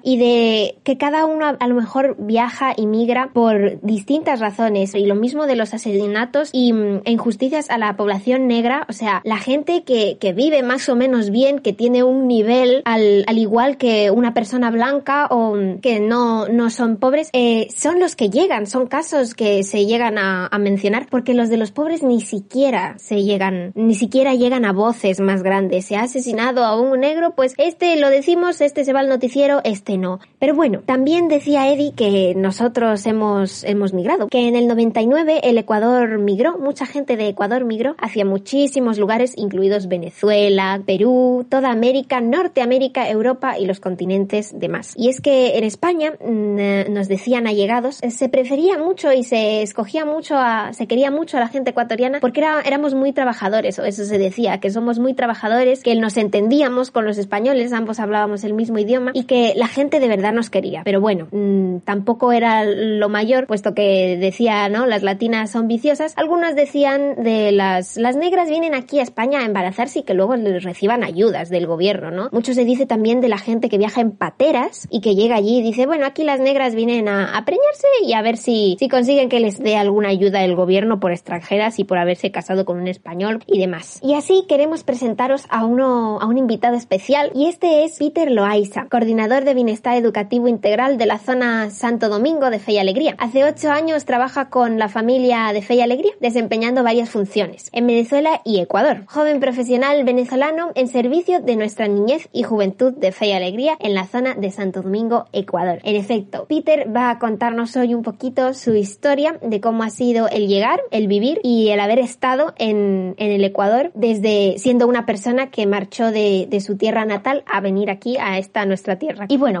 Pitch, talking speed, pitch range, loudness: 235 Hz, 195 wpm, 205-265 Hz, -17 LUFS